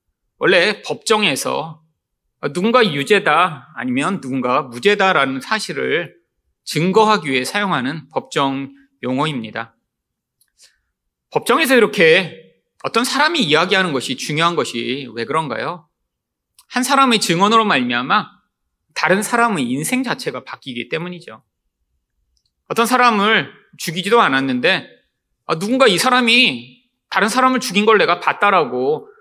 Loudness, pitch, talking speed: -16 LUFS, 190 Hz, 280 characters per minute